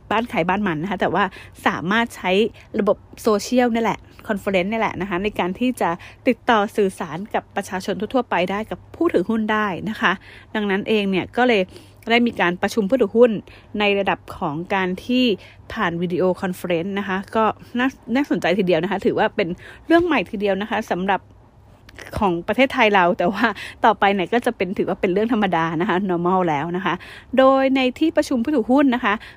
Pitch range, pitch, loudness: 185-235 Hz, 205 Hz, -20 LUFS